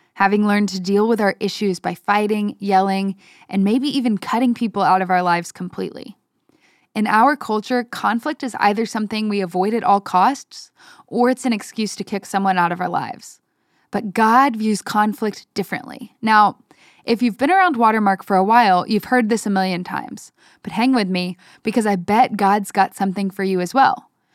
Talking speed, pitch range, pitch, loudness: 190 wpm, 195-235 Hz, 210 Hz, -18 LUFS